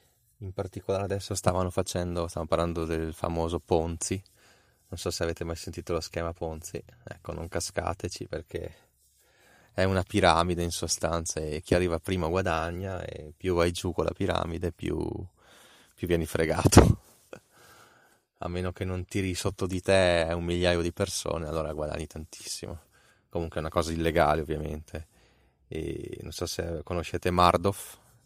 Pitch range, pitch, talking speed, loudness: 85-95 Hz, 85 Hz, 150 wpm, -29 LUFS